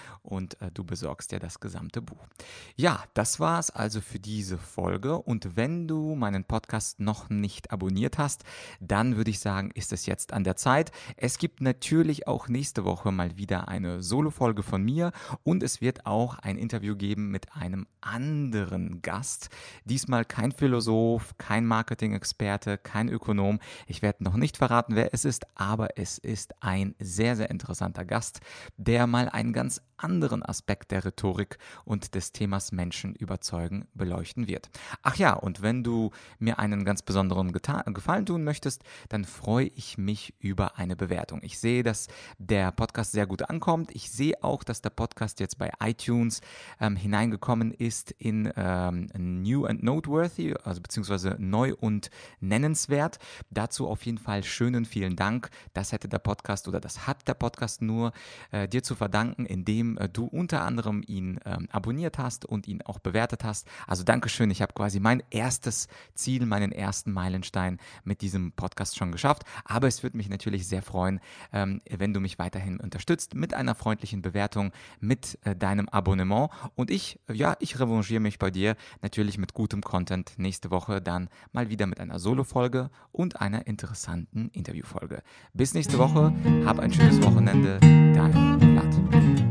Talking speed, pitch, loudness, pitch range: 170 wpm, 105 Hz, -28 LUFS, 95-120 Hz